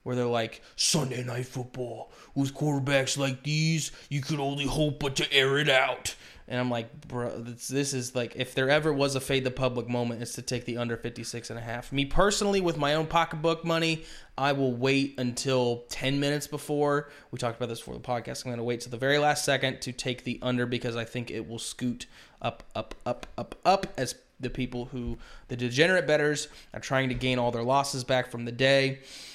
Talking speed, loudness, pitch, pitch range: 220 wpm, -28 LUFS, 130 Hz, 120-145 Hz